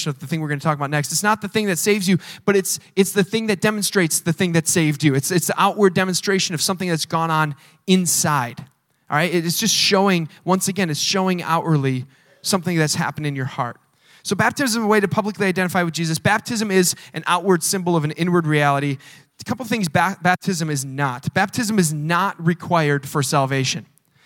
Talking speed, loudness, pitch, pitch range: 220 wpm, -19 LUFS, 170 Hz, 150-195 Hz